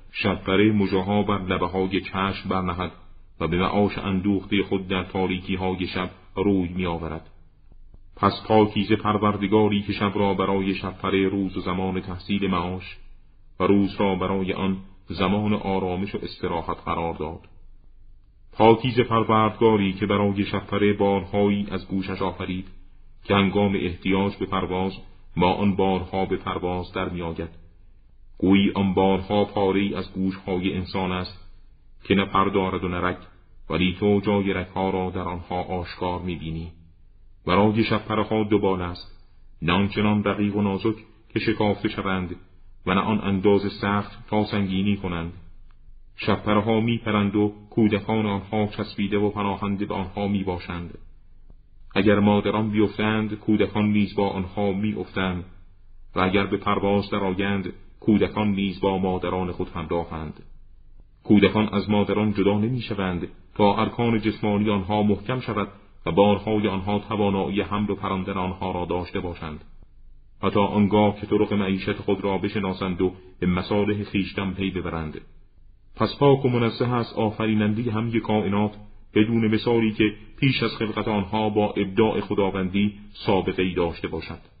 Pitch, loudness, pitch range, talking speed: 100 Hz, -24 LUFS, 95-105 Hz, 140 wpm